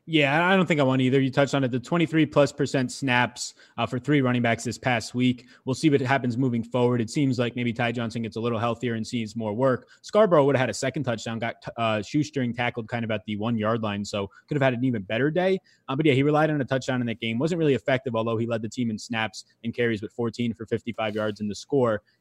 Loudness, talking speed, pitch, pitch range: -25 LUFS, 275 wpm, 125 Hz, 115-135 Hz